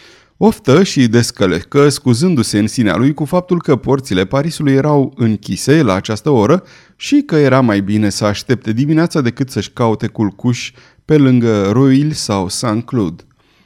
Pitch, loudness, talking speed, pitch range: 125 Hz, -14 LUFS, 150 wpm, 105-145 Hz